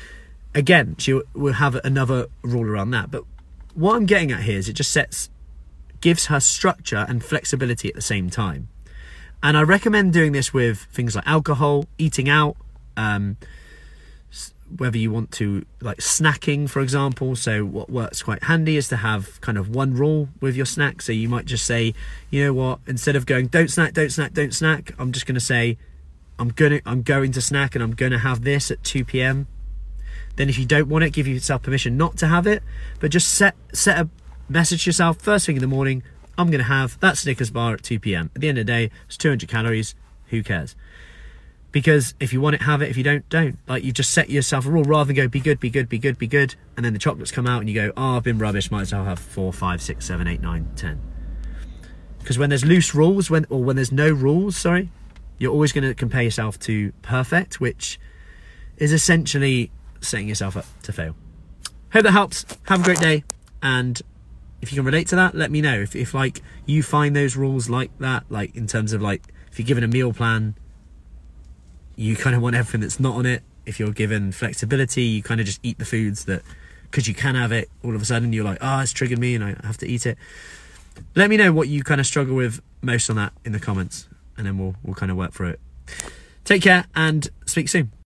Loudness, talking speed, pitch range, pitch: -20 LUFS, 230 wpm, 105-145 Hz, 125 Hz